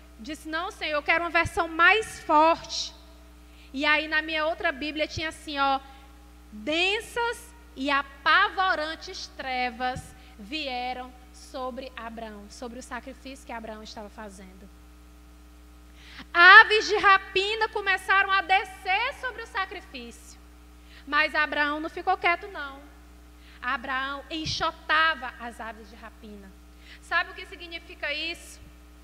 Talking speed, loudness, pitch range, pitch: 120 wpm, -24 LUFS, 220-345 Hz, 290 Hz